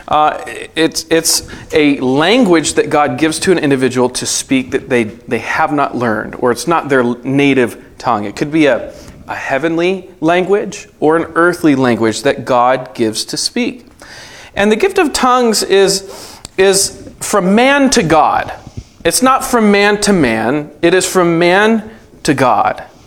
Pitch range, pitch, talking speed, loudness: 135-200 Hz, 165 Hz, 165 wpm, -12 LUFS